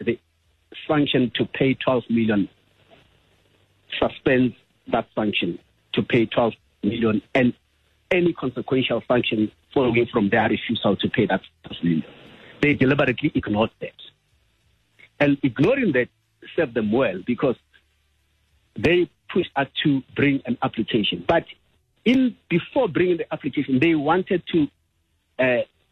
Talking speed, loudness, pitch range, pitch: 125 wpm, -22 LUFS, 105-145 Hz, 120 Hz